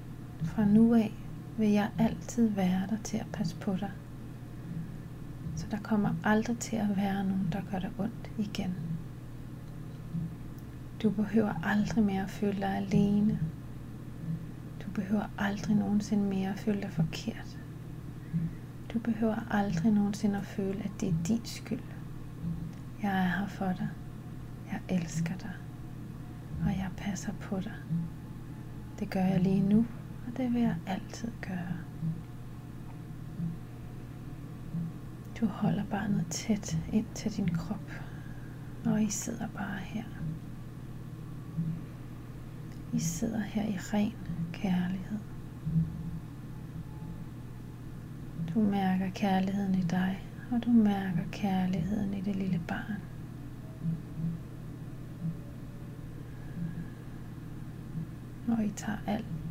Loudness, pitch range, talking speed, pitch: -33 LUFS, 140-200 Hz, 115 wpm, 165 Hz